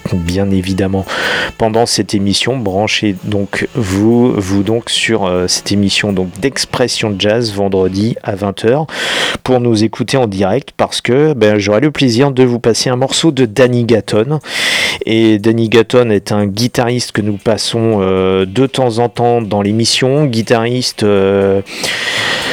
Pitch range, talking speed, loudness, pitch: 100-125 Hz, 150 wpm, -12 LUFS, 110 Hz